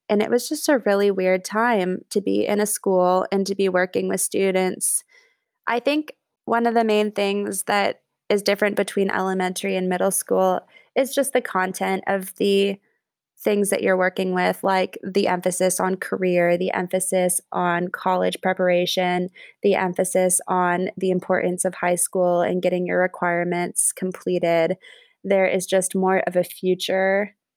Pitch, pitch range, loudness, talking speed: 185 Hz, 180-200 Hz, -21 LUFS, 165 wpm